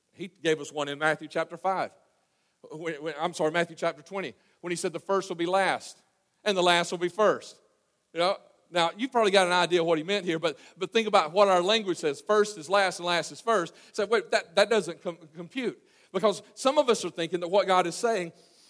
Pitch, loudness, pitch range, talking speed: 180 Hz, -27 LUFS, 170-205 Hz, 235 wpm